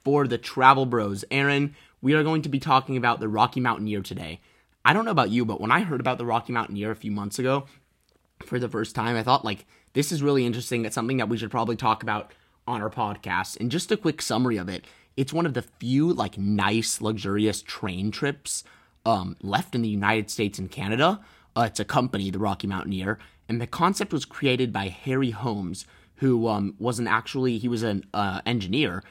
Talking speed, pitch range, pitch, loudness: 215 wpm, 105-130 Hz, 115 Hz, -25 LUFS